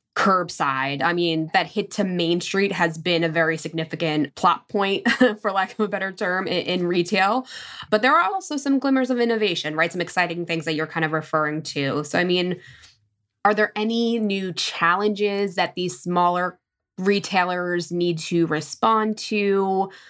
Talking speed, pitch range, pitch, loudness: 170 wpm, 165-205 Hz, 180 Hz, -22 LUFS